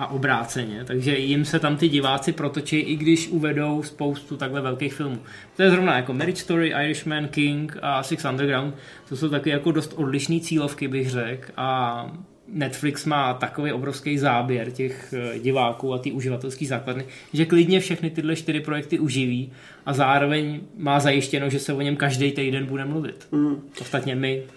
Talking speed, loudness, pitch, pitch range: 170 wpm, -24 LUFS, 140 Hz, 130-150 Hz